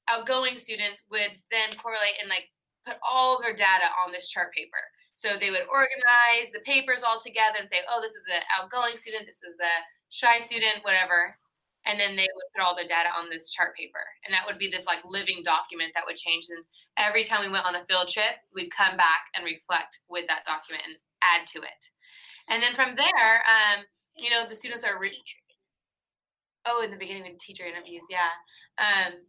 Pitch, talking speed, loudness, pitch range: 200 Hz, 210 wpm, -25 LUFS, 175-230 Hz